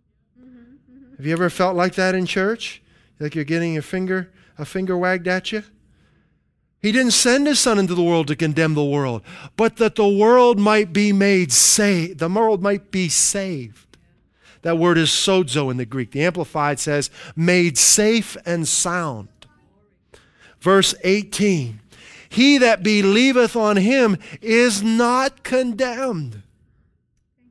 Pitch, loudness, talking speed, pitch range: 185 Hz, -18 LUFS, 145 wpm, 160-220 Hz